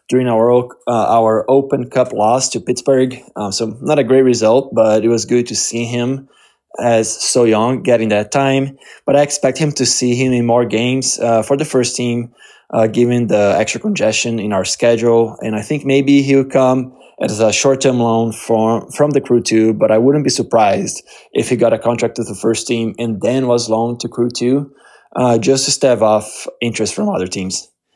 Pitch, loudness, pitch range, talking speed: 120 Hz, -14 LUFS, 110-130 Hz, 205 wpm